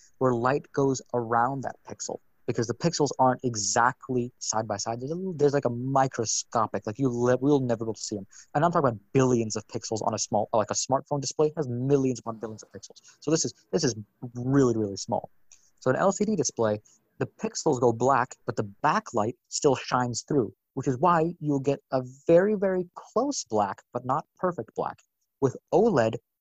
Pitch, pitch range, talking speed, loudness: 125 Hz, 115-145 Hz, 200 wpm, -27 LUFS